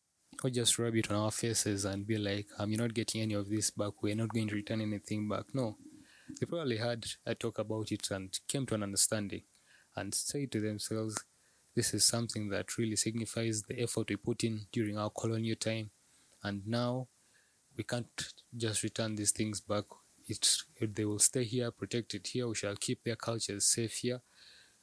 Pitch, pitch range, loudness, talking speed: 110 Hz, 105-115 Hz, -34 LUFS, 195 wpm